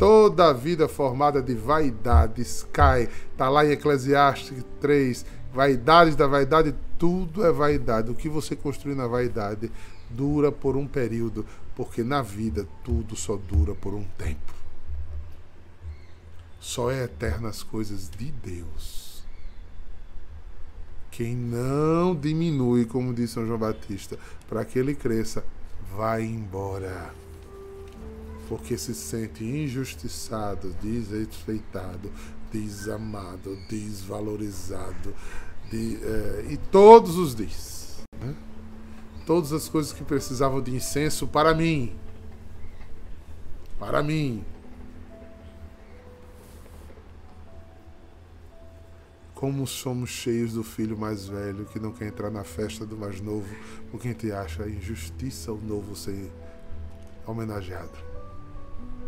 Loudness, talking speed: -25 LUFS, 110 wpm